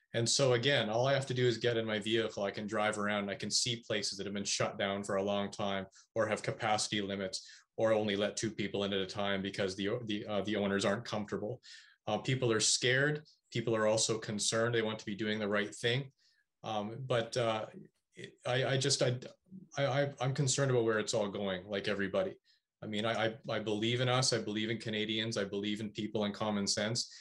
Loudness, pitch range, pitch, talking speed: -34 LUFS, 105-120 Hz, 110 Hz, 230 wpm